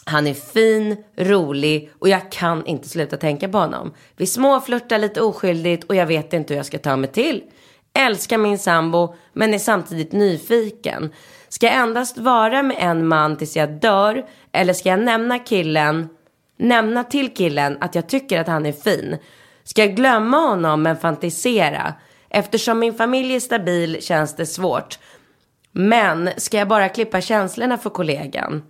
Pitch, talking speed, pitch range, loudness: 190 Hz, 165 wpm, 160-225 Hz, -18 LUFS